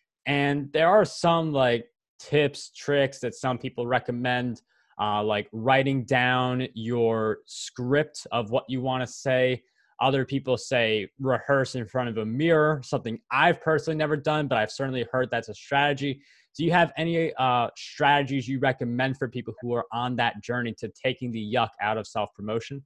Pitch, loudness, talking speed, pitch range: 130 Hz, -26 LUFS, 175 wpm, 120-140 Hz